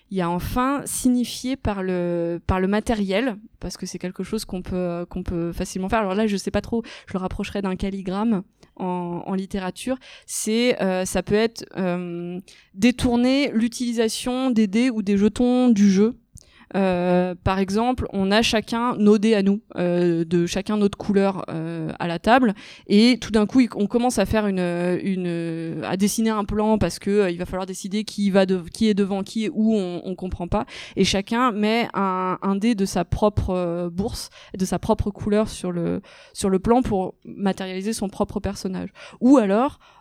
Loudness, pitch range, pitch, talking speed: -22 LUFS, 185-225 Hz, 200 Hz, 195 wpm